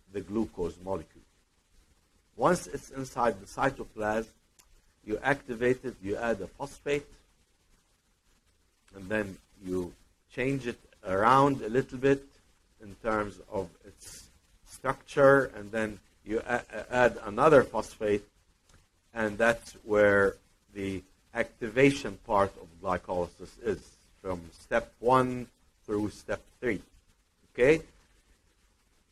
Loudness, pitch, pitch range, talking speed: -29 LUFS, 100 Hz, 85-115 Hz, 105 wpm